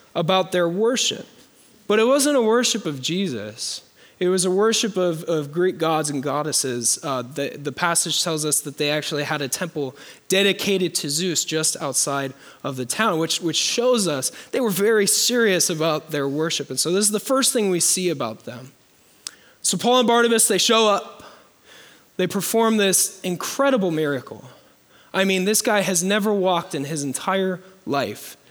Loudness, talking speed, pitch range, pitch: -20 LUFS, 180 wpm, 150-210 Hz, 180 Hz